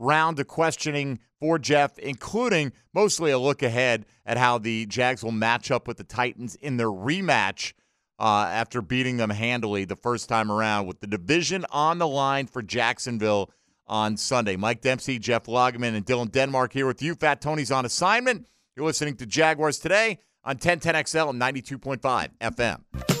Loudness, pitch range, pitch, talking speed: -25 LUFS, 115-150 Hz, 130 Hz, 170 wpm